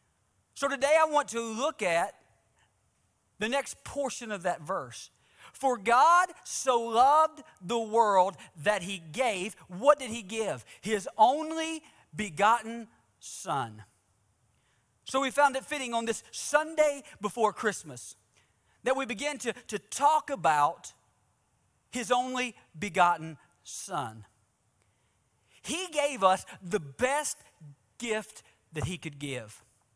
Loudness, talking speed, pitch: -29 LUFS, 120 wpm, 220 Hz